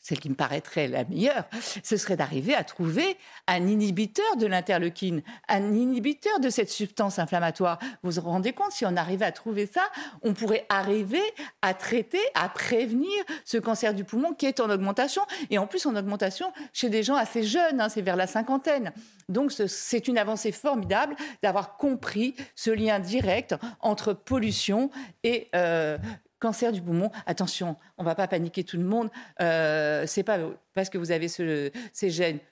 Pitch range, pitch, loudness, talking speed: 185-245 Hz, 215 Hz, -27 LUFS, 180 wpm